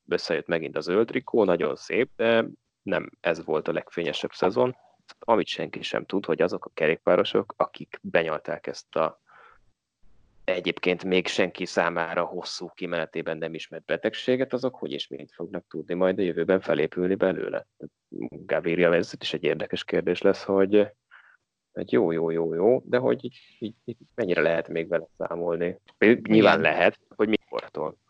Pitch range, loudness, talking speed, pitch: 85-115 Hz, -26 LUFS, 150 wpm, 95 Hz